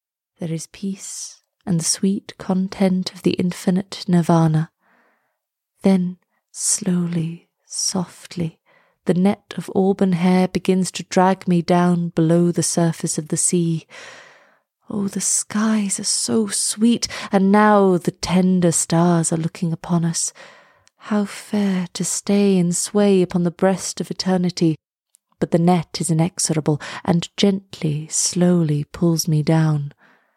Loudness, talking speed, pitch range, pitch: -19 LUFS, 130 wpm, 170-195 Hz, 180 Hz